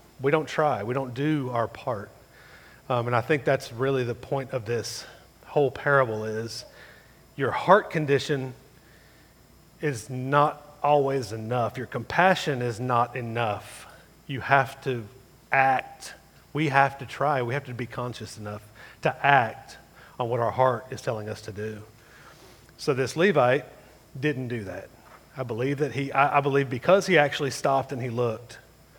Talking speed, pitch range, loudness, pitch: 160 wpm, 120-140 Hz, -26 LUFS, 130 Hz